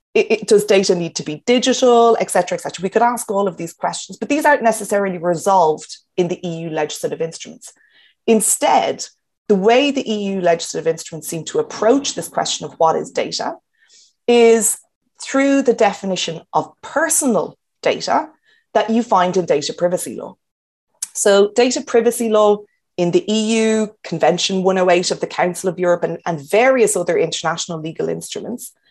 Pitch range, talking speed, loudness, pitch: 175-235 Hz, 165 wpm, -17 LUFS, 205 Hz